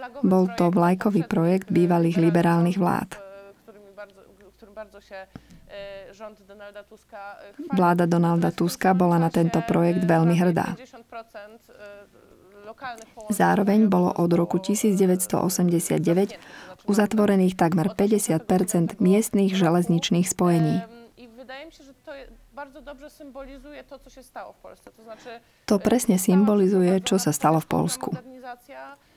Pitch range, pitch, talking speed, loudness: 175-220 Hz, 200 Hz, 70 wpm, -22 LUFS